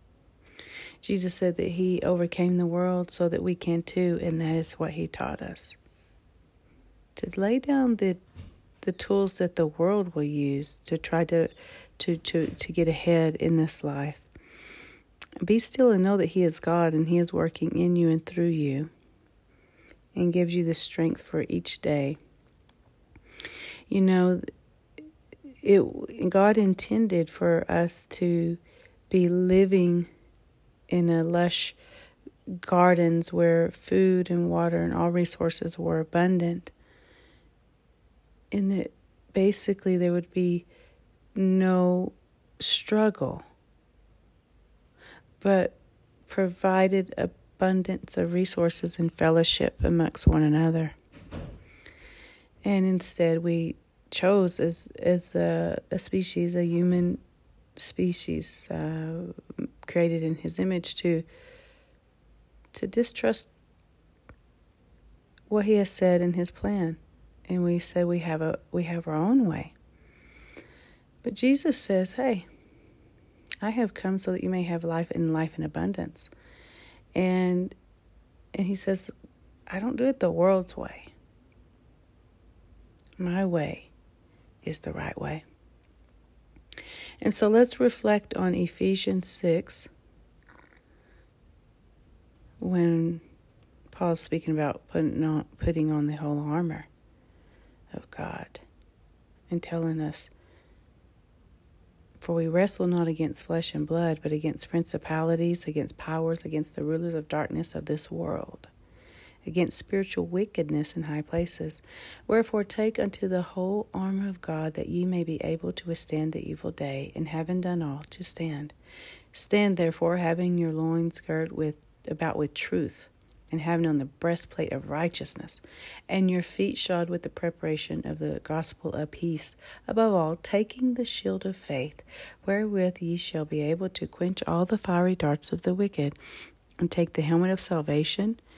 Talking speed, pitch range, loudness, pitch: 135 wpm, 150-185 Hz, -27 LUFS, 170 Hz